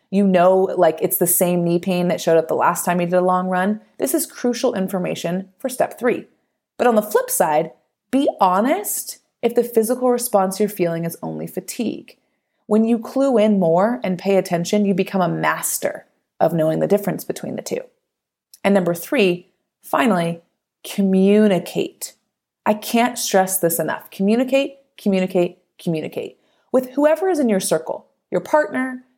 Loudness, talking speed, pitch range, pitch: -19 LUFS, 170 wpm, 180-245 Hz, 195 Hz